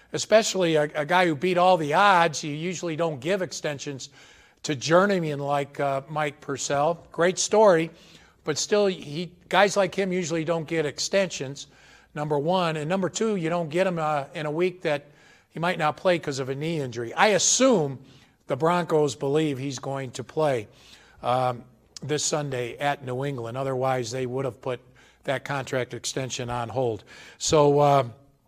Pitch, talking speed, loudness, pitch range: 150 Hz, 175 wpm, -25 LUFS, 135-175 Hz